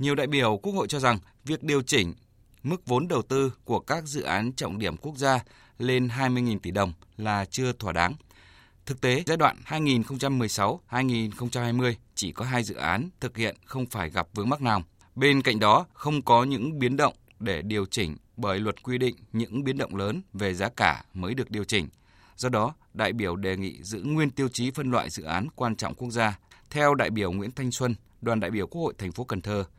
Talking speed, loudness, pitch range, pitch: 215 wpm, -27 LUFS, 100-130 Hz, 115 Hz